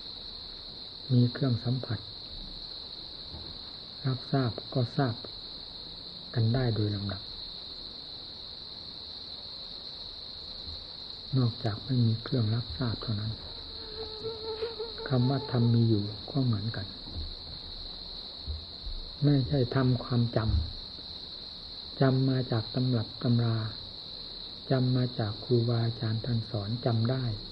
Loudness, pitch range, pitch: -32 LUFS, 90-125 Hz, 110 Hz